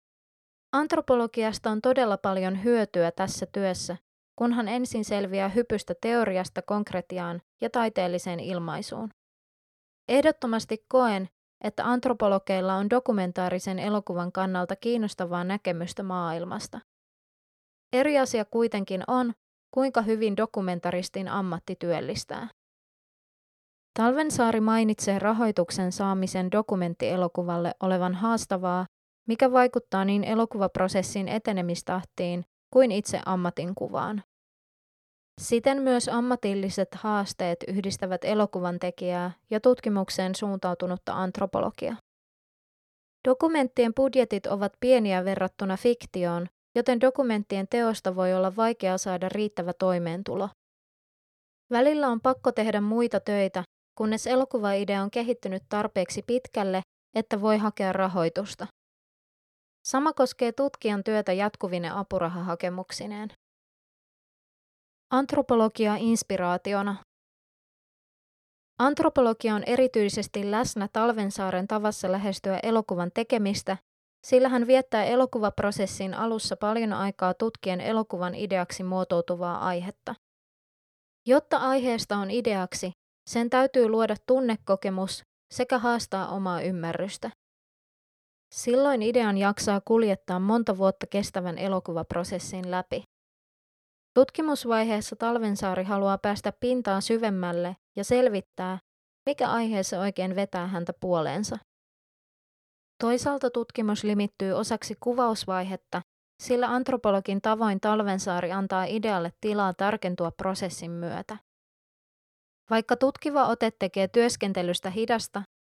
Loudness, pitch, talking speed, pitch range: -27 LUFS, 205 Hz, 95 wpm, 185-235 Hz